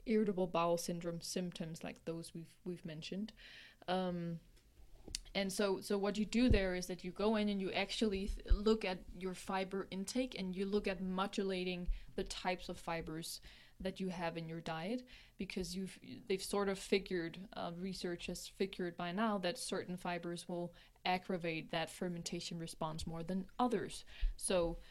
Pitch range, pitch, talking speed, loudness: 175-200 Hz, 185 Hz, 170 wpm, -40 LUFS